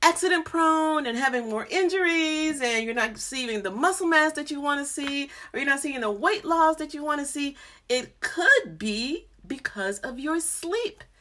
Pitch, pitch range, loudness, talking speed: 305 Hz, 260-335 Hz, -25 LUFS, 200 wpm